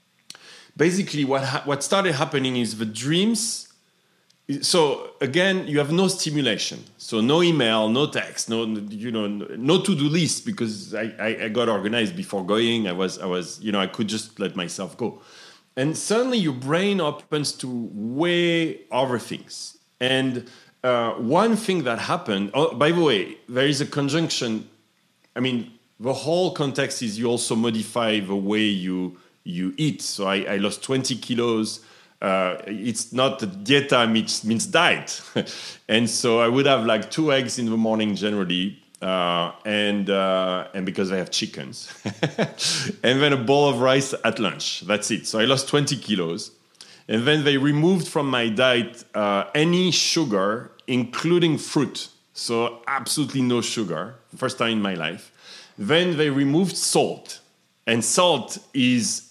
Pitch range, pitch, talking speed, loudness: 110-155 Hz, 130 Hz, 165 wpm, -22 LUFS